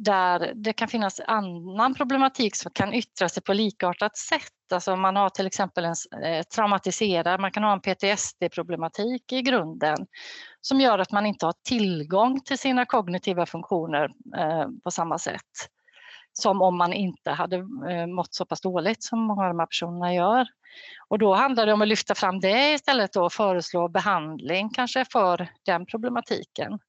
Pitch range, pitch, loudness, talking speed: 180-235 Hz, 195 Hz, -25 LUFS, 165 wpm